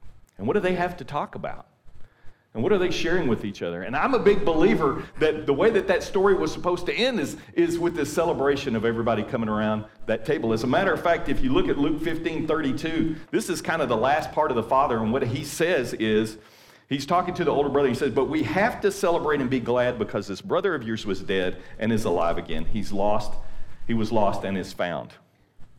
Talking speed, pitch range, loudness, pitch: 240 wpm, 110-170 Hz, -24 LUFS, 130 Hz